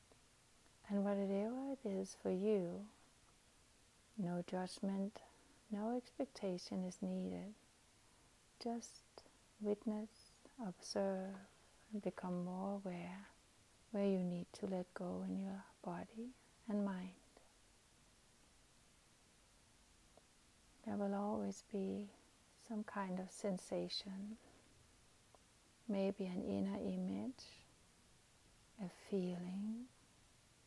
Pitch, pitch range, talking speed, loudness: 195 Hz, 185-210 Hz, 85 wpm, -45 LUFS